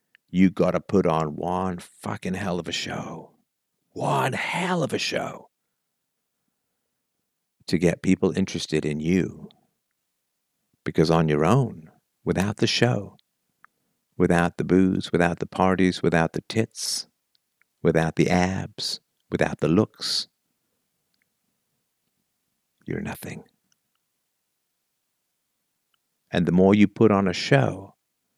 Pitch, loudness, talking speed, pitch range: 90 Hz, -23 LUFS, 110 wpm, 80-95 Hz